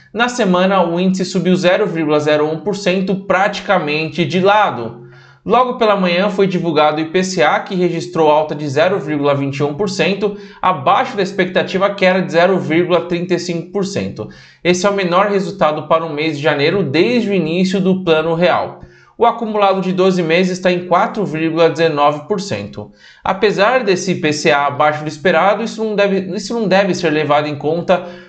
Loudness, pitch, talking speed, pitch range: -15 LUFS, 180 Hz, 145 wpm, 155-195 Hz